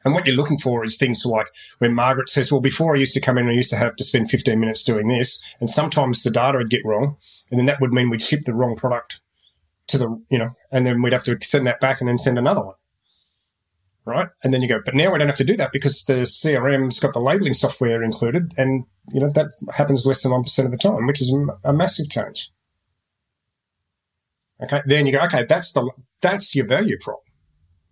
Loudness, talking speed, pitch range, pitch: -19 LUFS, 235 wpm, 120-140 Hz, 130 Hz